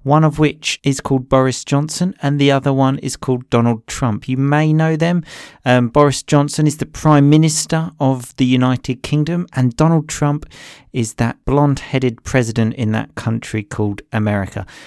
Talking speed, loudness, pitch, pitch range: 175 wpm, -16 LUFS, 135 Hz, 120-150 Hz